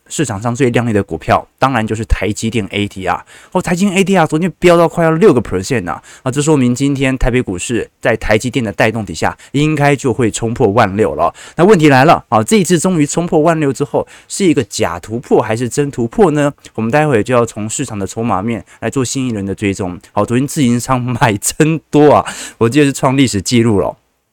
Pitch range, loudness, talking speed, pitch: 110-145 Hz, -13 LUFS, 350 characters per minute, 125 Hz